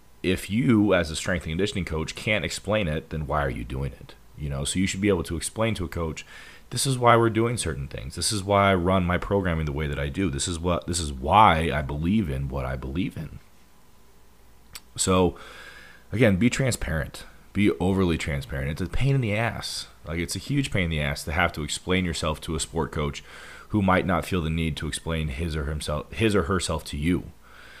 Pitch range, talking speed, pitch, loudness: 75-95 Hz, 230 wpm, 85 Hz, -25 LUFS